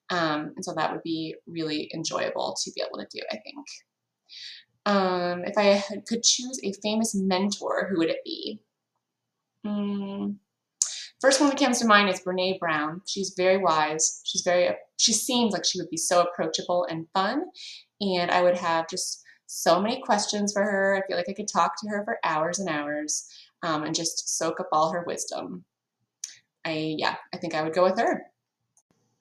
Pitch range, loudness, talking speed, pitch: 165-205 Hz, -26 LUFS, 190 wpm, 185 Hz